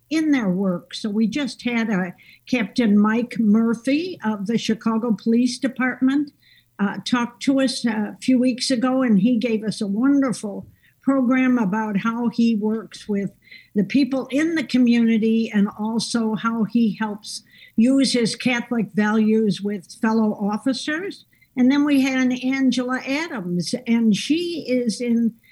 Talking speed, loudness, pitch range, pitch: 150 wpm, -21 LUFS, 215-255 Hz, 230 Hz